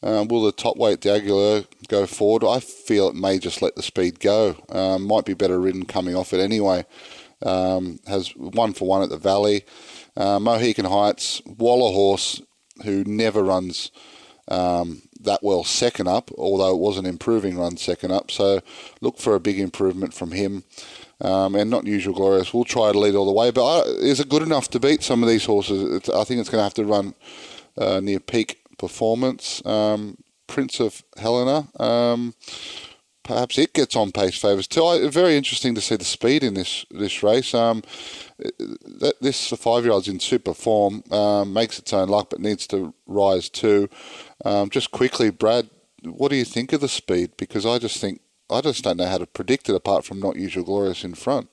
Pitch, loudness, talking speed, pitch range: 105 Hz, -21 LUFS, 200 wpm, 95-115 Hz